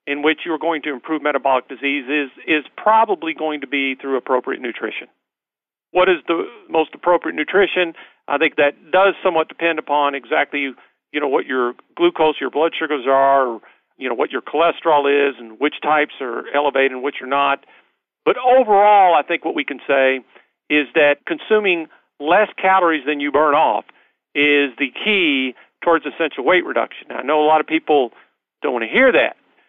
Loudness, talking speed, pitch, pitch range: -18 LUFS, 185 wpm, 150 Hz, 140-165 Hz